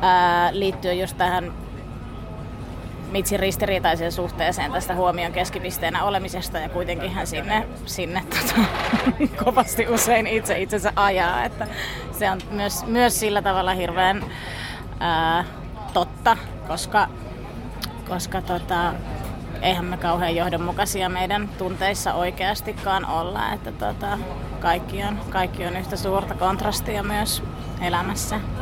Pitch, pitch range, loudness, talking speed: 185 Hz, 175-200 Hz, -23 LUFS, 110 wpm